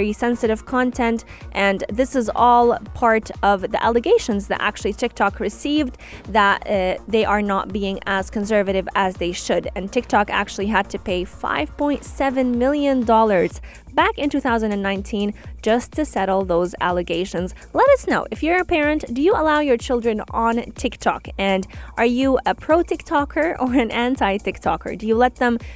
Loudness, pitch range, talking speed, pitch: -20 LUFS, 200-260 Hz, 155 wpm, 230 Hz